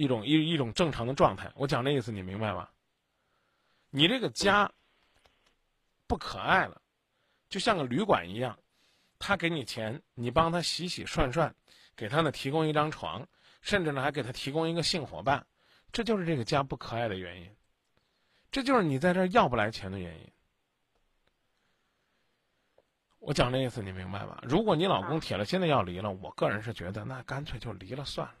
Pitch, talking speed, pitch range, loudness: 140 Hz, 265 characters per minute, 110-165 Hz, -30 LUFS